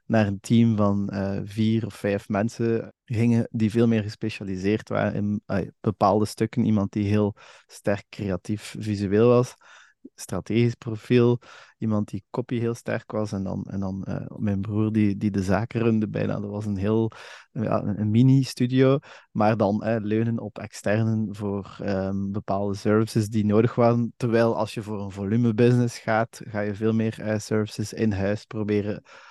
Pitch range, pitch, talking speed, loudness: 100-115 Hz, 110 Hz, 170 wpm, -25 LUFS